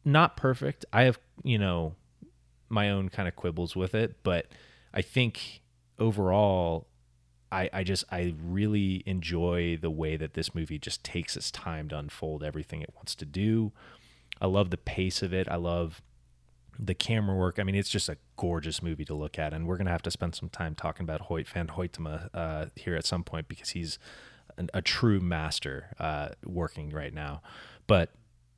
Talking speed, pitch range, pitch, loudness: 190 wpm, 80-100 Hz, 85 Hz, -31 LUFS